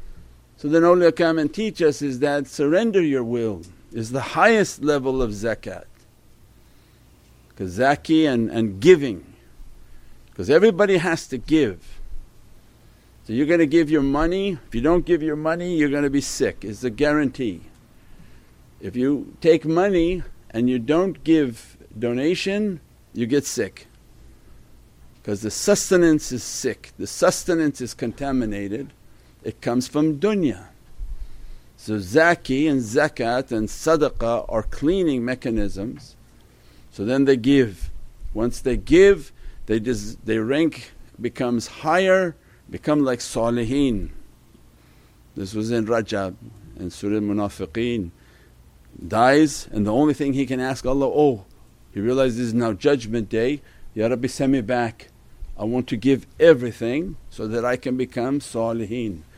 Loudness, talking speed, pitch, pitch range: -21 LUFS, 140 wpm, 125 Hz, 110-150 Hz